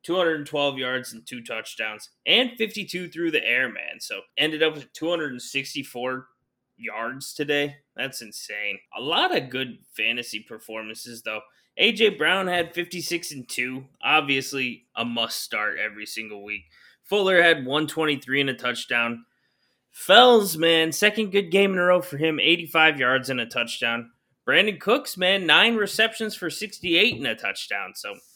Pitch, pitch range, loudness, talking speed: 145 Hz, 125-175 Hz, -22 LUFS, 150 wpm